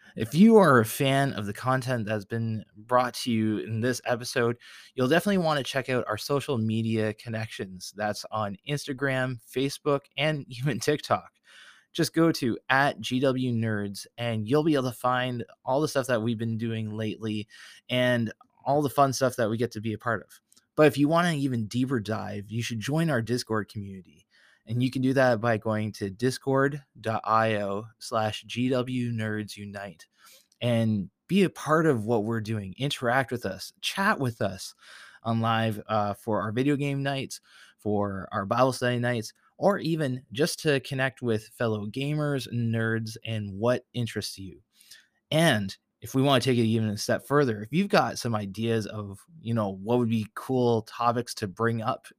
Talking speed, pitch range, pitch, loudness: 180 wpm, 110-135 Hz, 120 Hz, -27 LUFS